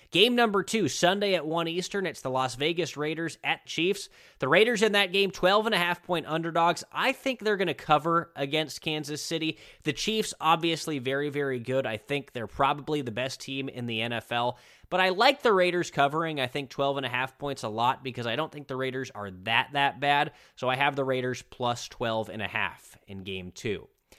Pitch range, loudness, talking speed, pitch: 130-175 Hz, -27 LUFS, 195 wpm, 145 Hz